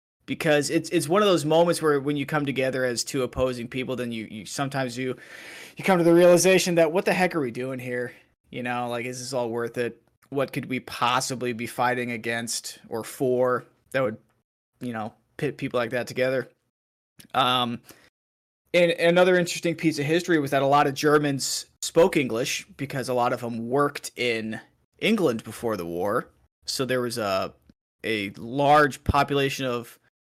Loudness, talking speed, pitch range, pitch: -24 LUFS, 190 wpm, 120-145 Hz, 130 Hz